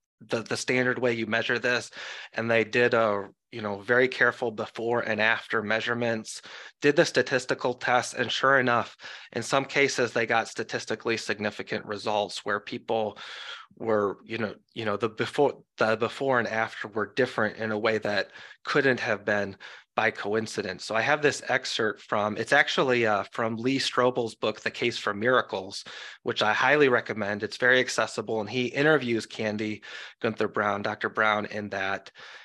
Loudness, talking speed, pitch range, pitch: -26 LUFS, 170 wpm, 105-120 Hz, 115 Hz